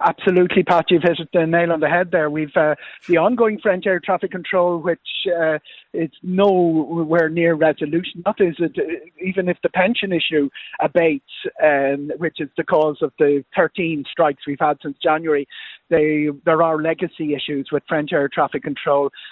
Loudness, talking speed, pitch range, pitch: -19 LUFS, 175 wpm, 150-180 Hz, 165 Hz